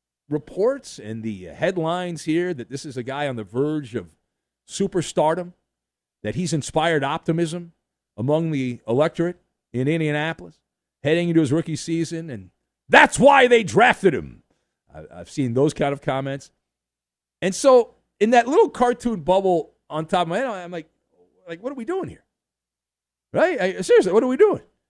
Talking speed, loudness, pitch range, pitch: 165 wpm, -21 LUFS, 120-180 Hz, 155 Hz